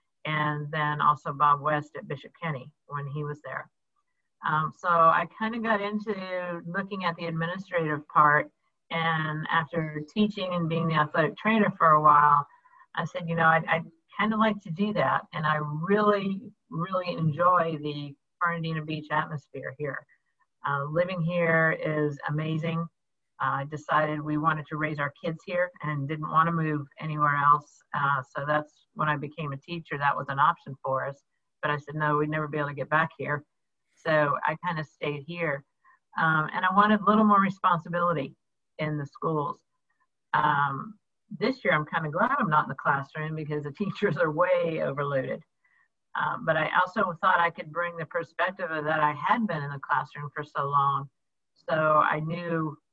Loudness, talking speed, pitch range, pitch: -27 LUFS, 185 wpm, 150-175 Hz, 155 Hz